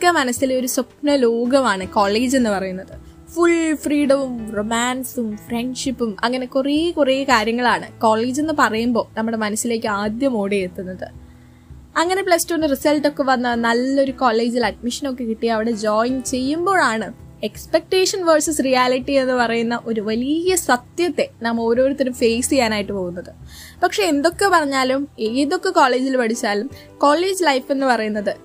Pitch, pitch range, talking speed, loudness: 255 Hz, 230-290 Hz, 125 wpm, -19 LUFS